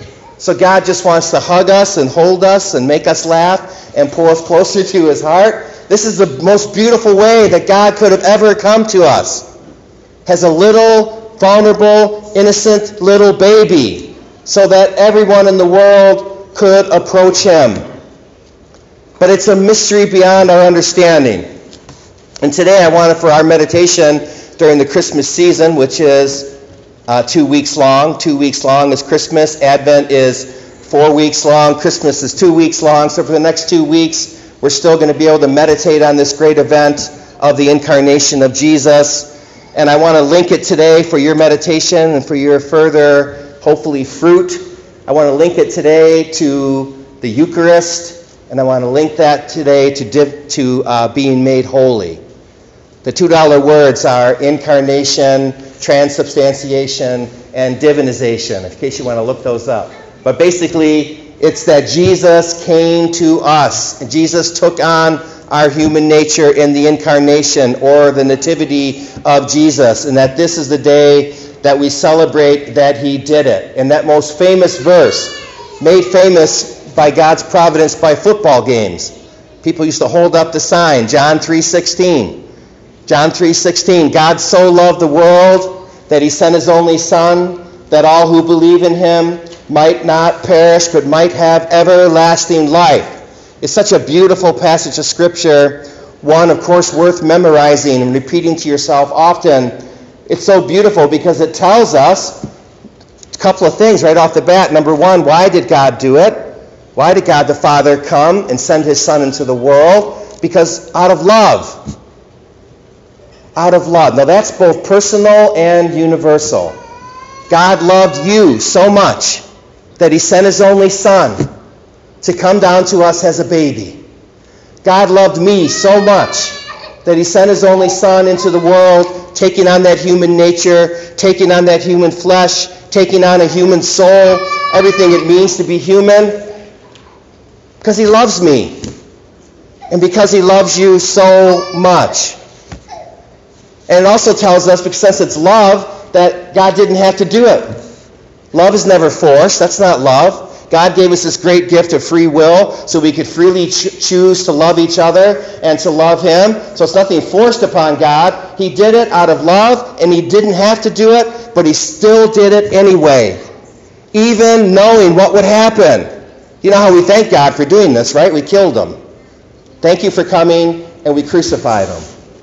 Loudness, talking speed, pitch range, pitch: -8 LUFS, 165 wpm, 150-190 Hz, 170 Hz